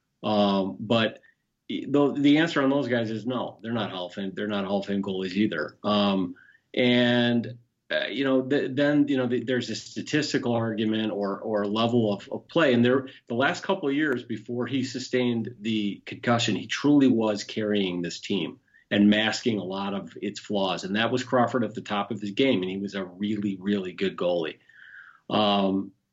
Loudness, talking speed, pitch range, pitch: -26 LUFS, 195 wpm, 100-130 Hz, 115 Hz